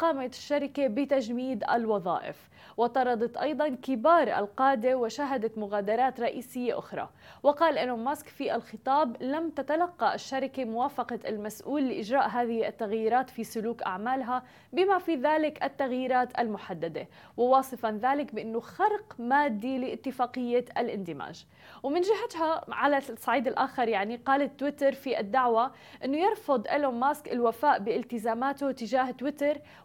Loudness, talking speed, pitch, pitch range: -29 LUFS, 115 wpm, 260 Hz, 235-285 Hz